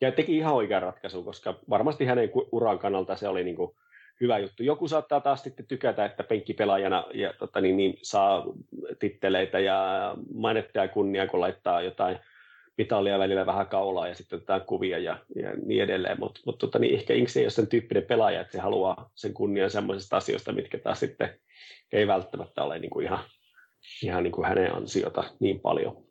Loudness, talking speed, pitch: -28 LUFS, 180 wpm, 130 Hz